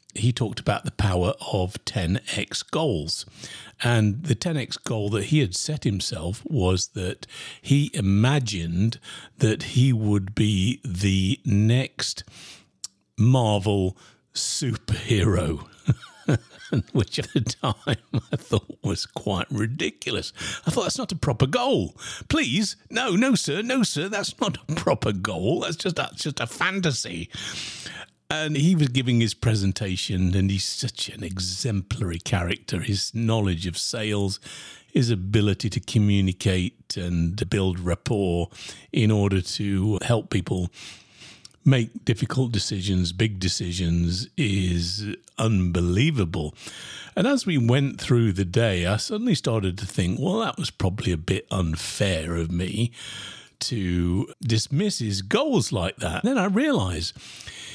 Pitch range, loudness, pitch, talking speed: 95-125 Hz, -25 LUFS, 105 Hz, 135 wpm